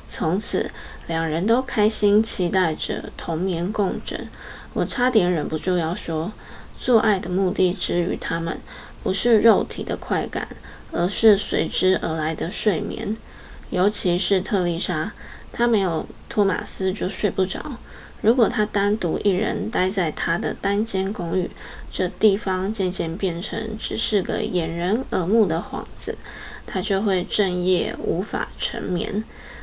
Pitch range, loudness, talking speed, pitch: 180-215 Hz, -23 LUFS, 210 characters per minute, 190 Hz